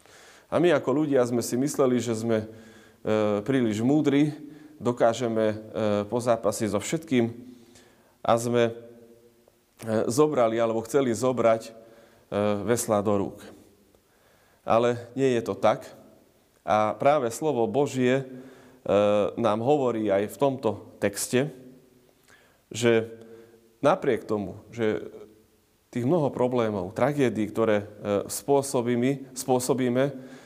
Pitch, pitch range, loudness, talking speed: 115 Hz, 110-130 Hz, -25 LUFS, 100 wpm